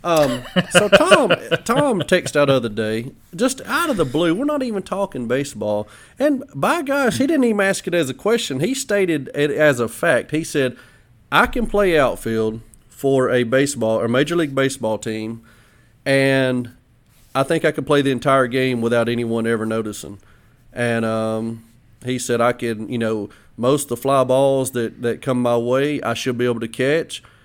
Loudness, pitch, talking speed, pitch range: -19 LUFS, 130 Hz, 190 wpm, 115-155 Hz